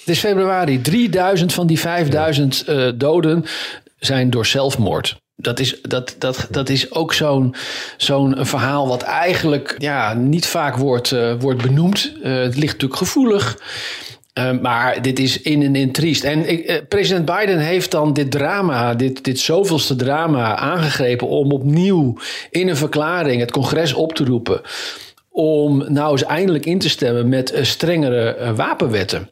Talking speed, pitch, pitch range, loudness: 170 wpm, 145 Hz, 130-170 Hz, -17 LUFS